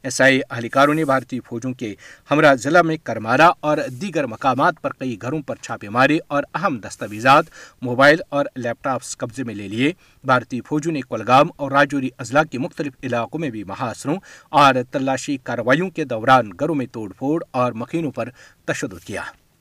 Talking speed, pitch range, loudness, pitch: 175 wpm, 120-150 Hz, -19 LUFS, 130 Hz